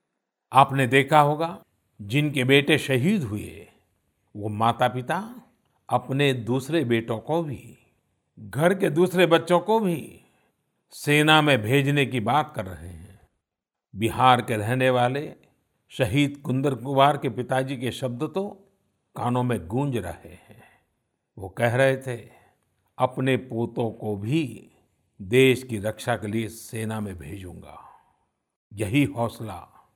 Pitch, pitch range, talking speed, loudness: 125 Hz, 110-145 Hz, 130 wpm, -23 LUFS